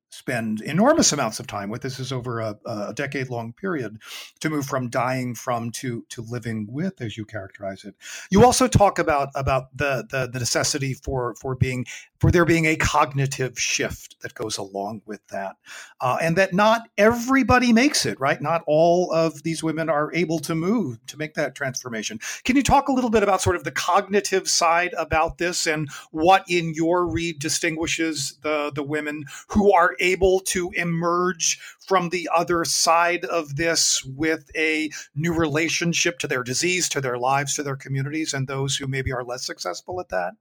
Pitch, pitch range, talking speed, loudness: 155 Hz, 130-170 Hz, 185 wpm, -22 LUFS